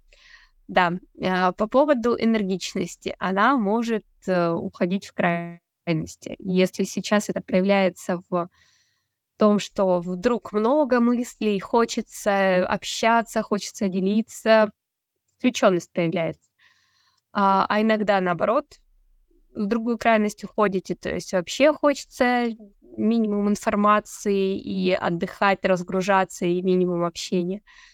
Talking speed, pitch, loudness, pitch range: 95 wpm, 200 Hz, -23 LUFS, 185-225 Hz